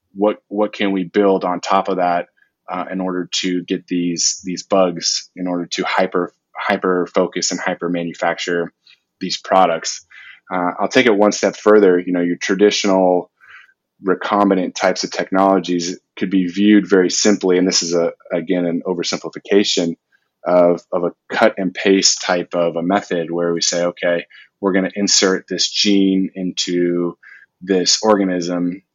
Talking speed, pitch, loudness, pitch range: 160 wpm, 90 Hz, -17 LUFS, 85-95 Hz